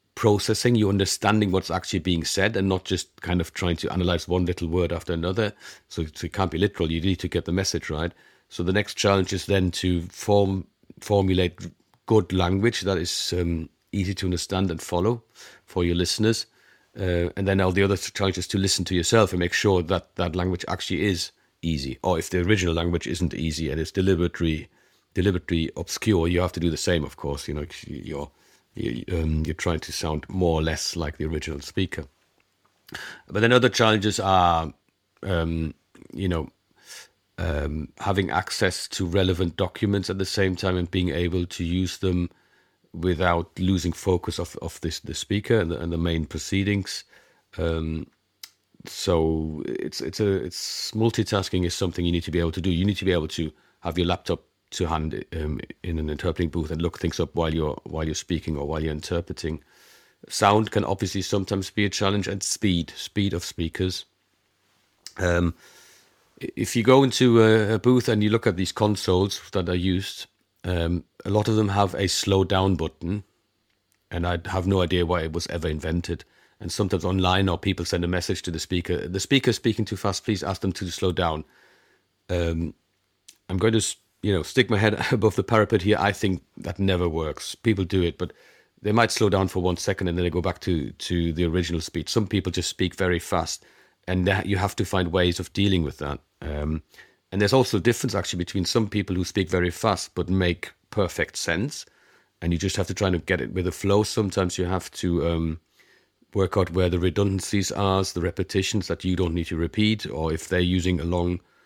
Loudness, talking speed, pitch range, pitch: -25 LUFS, 205 wpm, 85-100 Hz, 90 Hz